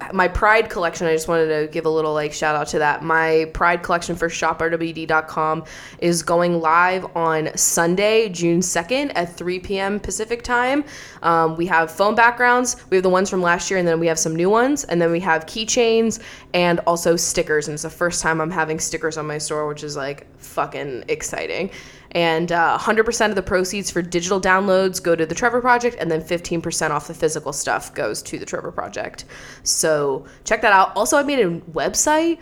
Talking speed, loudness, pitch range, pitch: 205 wpm, -19 LUFS, 160-200 Hz, 170 Hz